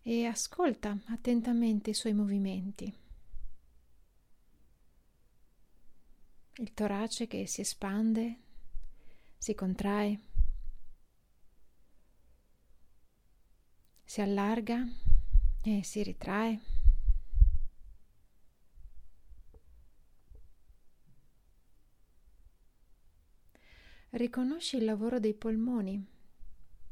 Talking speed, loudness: 50 wpm, -34 LUFS